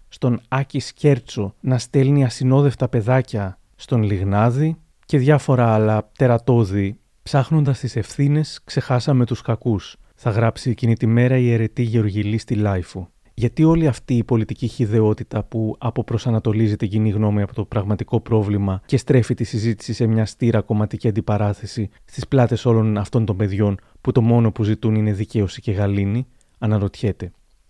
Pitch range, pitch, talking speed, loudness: 105-125 Hz, 115 Hz, 150 wpm, -20 LUFS